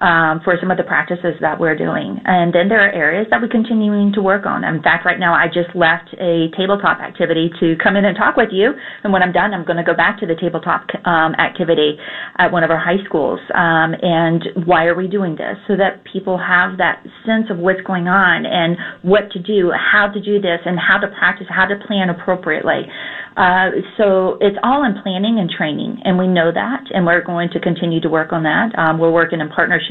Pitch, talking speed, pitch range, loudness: 180 Hz, 235 wpm, 170-200 Hz, -15 LUFS